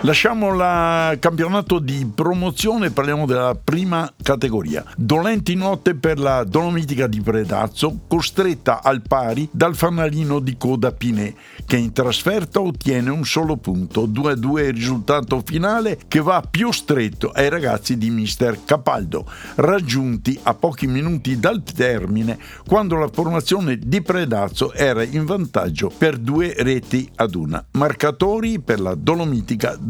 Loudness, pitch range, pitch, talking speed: -19 LUFS, 125-170 Hz, 145 Hz, 135 wpm